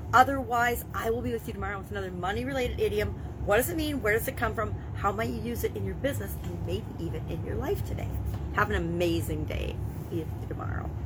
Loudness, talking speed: -30 LUFS, 230 wpm